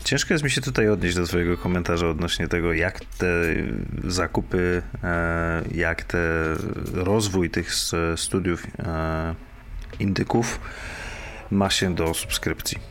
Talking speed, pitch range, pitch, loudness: 110 wpm, 85-105 Hz, 90 Hz, -24 LUFS